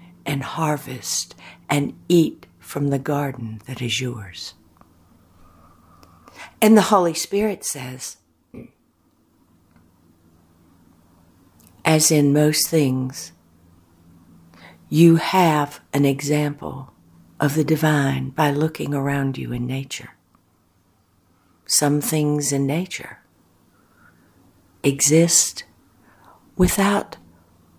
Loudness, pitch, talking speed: -20 LUFS, 130 Hz, 80 wpm